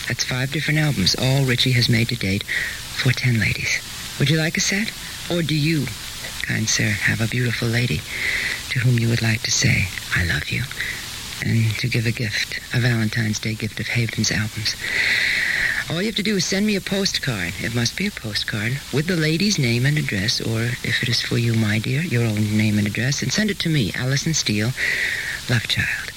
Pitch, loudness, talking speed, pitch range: 120 Hz, -20 LUFS, 210 wpm, 110-150 Hz